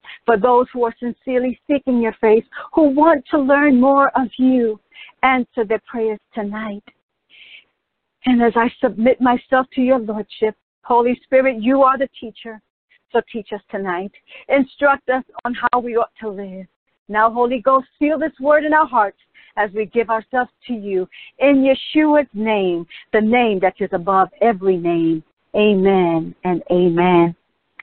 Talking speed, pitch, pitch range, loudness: 155 wpm, 235 Hz, 210-265 Hz, -17 LUFS